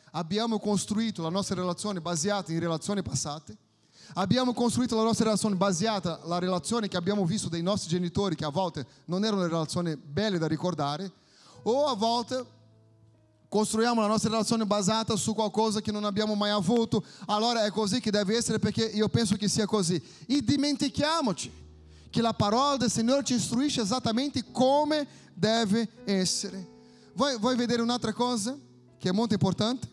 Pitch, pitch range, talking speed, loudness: 210 Hz, 180-230 Hz, 160 wpm, -28 LUFS